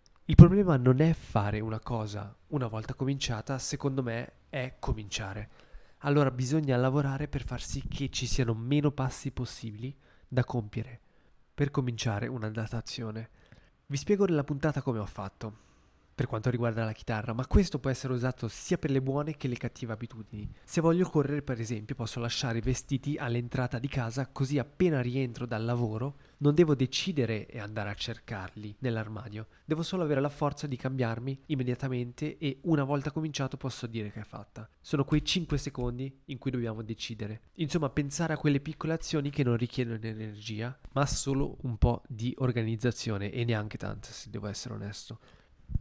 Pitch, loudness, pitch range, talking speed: 125 Hz, -31 LUFS, 115-140 Hz, 170 wpm